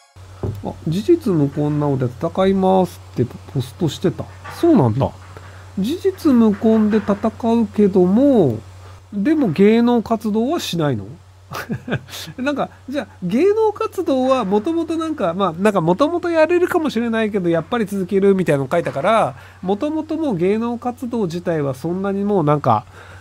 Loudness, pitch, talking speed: -18 LUFS, 200 Hz, 320 characters per minute